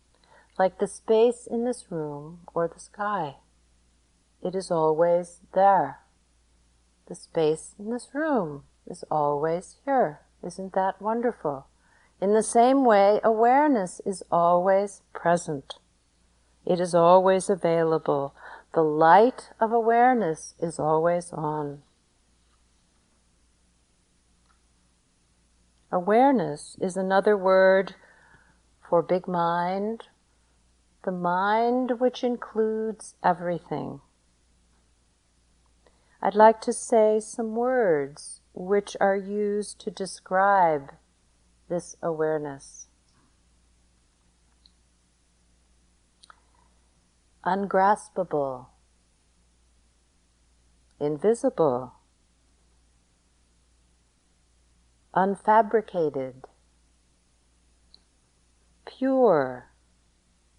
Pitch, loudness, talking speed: 150 Hz, -24 LUFS, 70 wpm